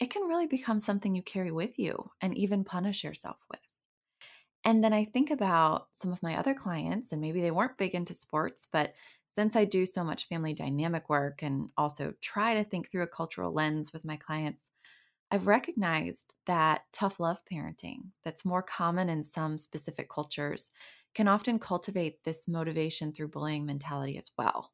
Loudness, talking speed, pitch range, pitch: -32 LUFS, 180 wpm, 155-205 Hz, 175 Hz